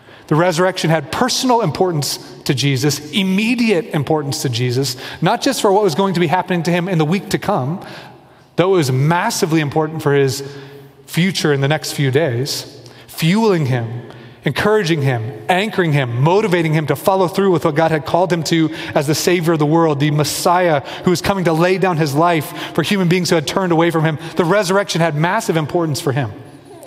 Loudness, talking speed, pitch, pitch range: -16 LUFS, 200 wpm, 165 Hz, 145-185 Hz